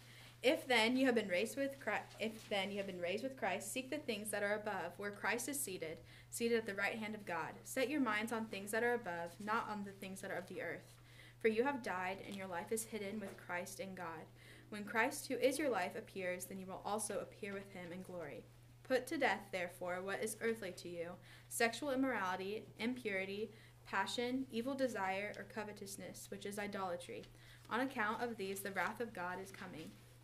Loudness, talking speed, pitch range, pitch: -41 LUFS, 215 wpm, 180-230 Hz, 205 Hz